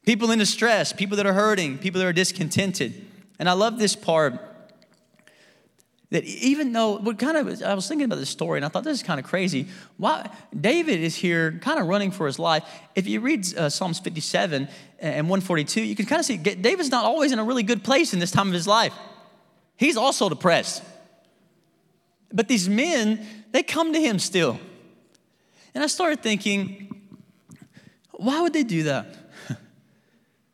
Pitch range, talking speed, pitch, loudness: 180-235 Hz, 185 wpm, 205 Hz, -23 LUFS